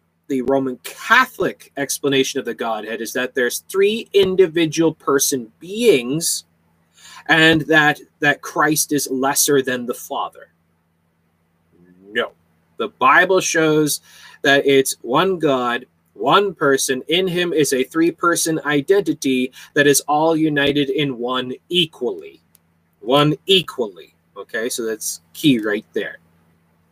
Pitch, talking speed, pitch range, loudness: 140 Hz, 125 wpm, 115-160 Hz, -18 LUFS